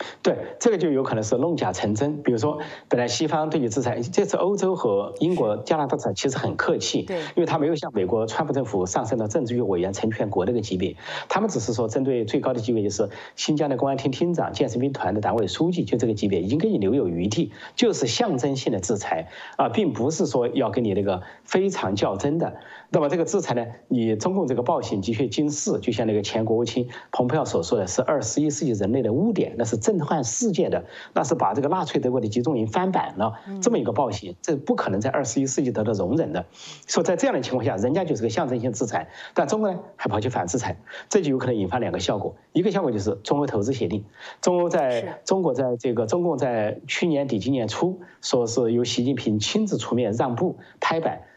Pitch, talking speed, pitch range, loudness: 130 Hz, 355 characters per minute, 115-160 Hz, -24 LUFS